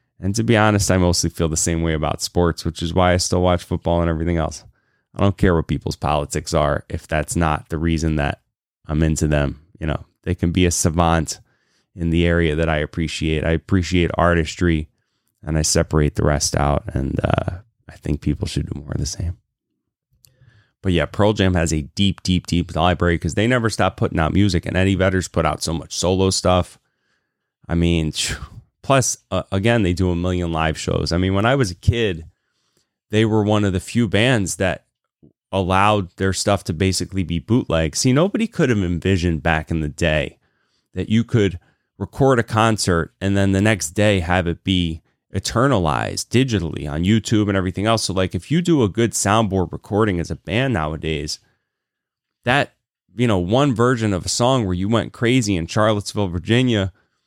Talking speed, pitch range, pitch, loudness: 200 wpm, 85-105 Hz, 90 Hz, -19 LUFS